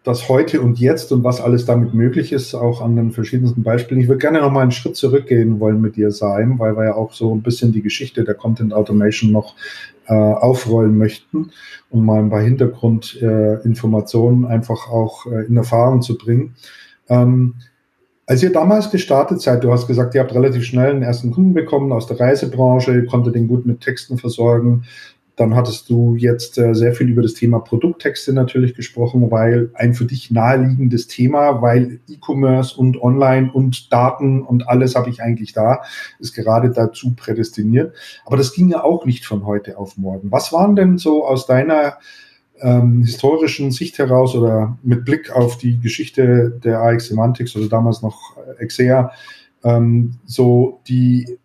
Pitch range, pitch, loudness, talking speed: 115-130 Hz, 120 Hz, -15 LUFS, 180 wpm